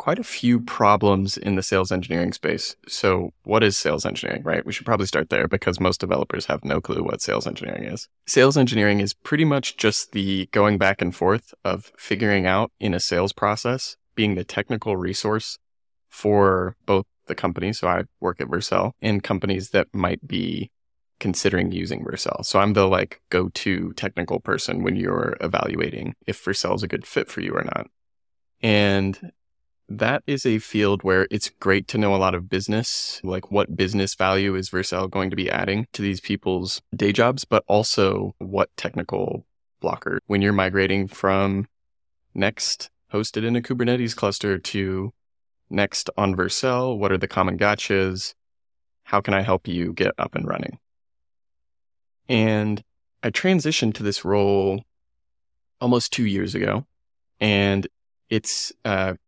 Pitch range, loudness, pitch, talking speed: 95-105 Hz, -23 LUFS, 100 Hz, 165 wpm